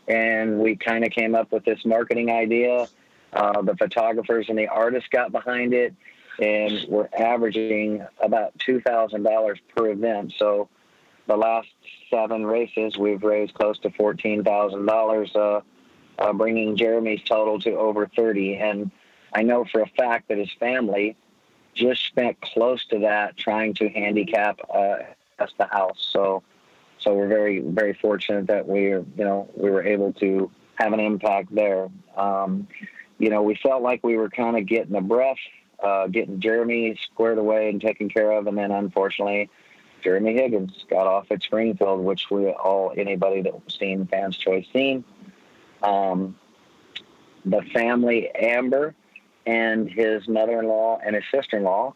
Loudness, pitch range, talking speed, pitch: -23 LUFS, 100-115 Hz, 155 wpm, 110 Hz